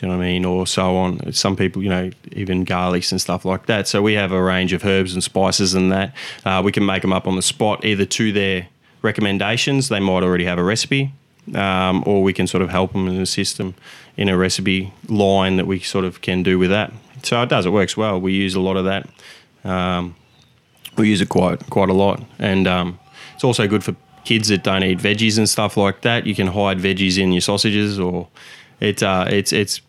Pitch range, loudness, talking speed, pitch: 95-105 Hz, -18 LUFS, 240 wpm, 95 Hz